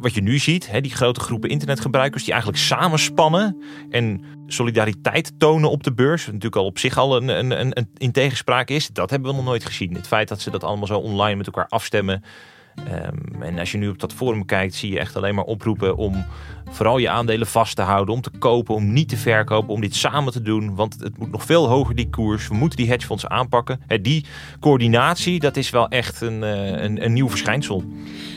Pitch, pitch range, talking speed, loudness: 115 Hz, 105-135 Hz, 220 wpm, -20 LUFS